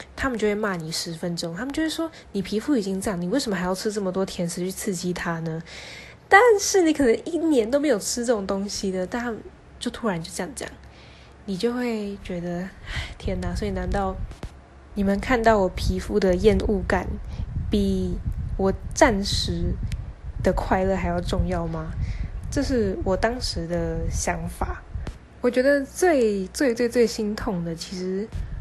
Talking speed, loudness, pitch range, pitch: 245 characters per minute, -24 LUFS, 170-240 Hz, 195 Hz